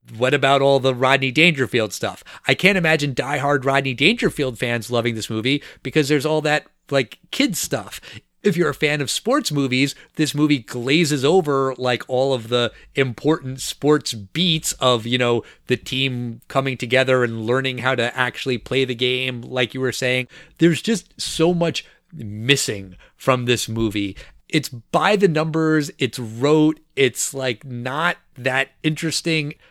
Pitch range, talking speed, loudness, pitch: 125-155 Hz, 165 wpm, -20 LUFS, 135 Hz